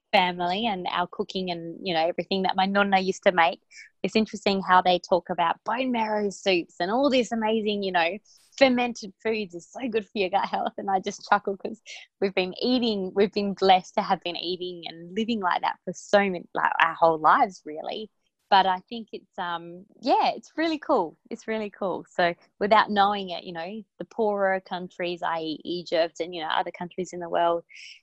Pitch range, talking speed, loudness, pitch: 175-215 Hz, 205 wpm, -25 LUFS, 190 Hz